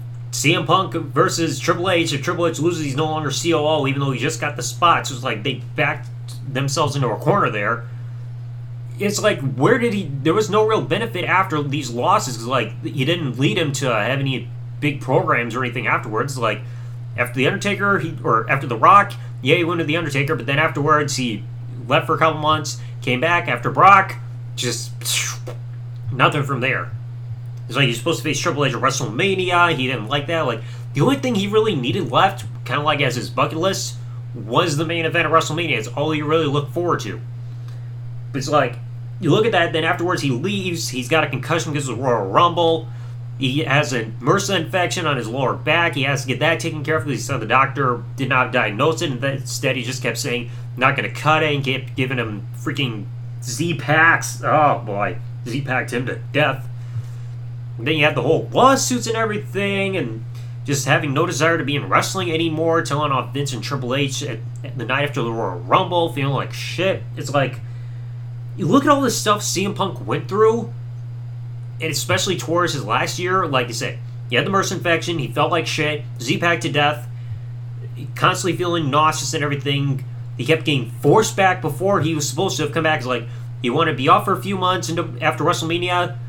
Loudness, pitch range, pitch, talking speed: -19 LUFS, 120-155 Hz, 130 Hz, 210 wpm